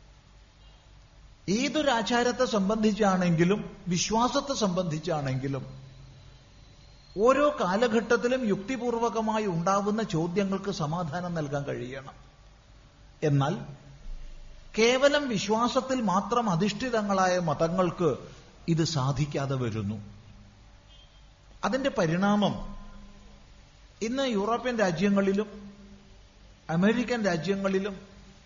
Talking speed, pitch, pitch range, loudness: 60 wpm, 195 Hz, 145-220 Hz, -27 LUFS